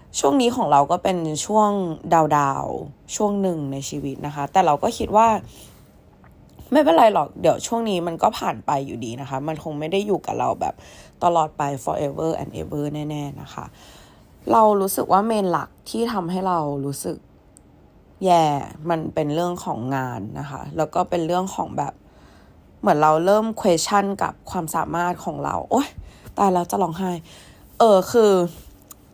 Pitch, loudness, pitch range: 170 Hz, -21 LUFS, 145-190 Hz